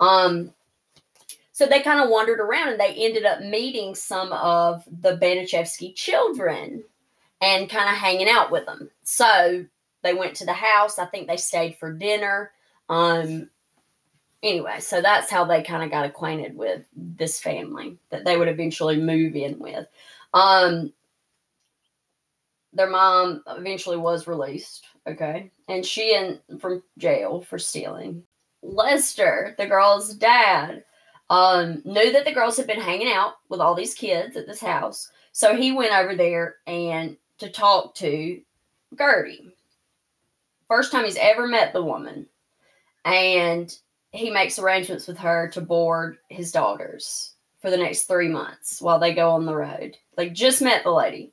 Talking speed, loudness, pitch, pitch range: 155 wpm, -21 LUFS, 180 Hz, 170-210 Hz